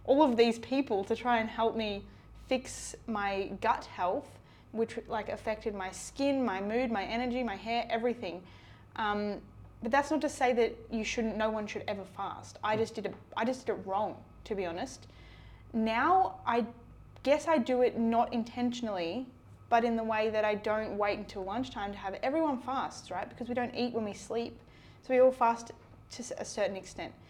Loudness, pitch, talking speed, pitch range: -32 LUFS, 230 Hz, 200 wpm, 210-245 Hz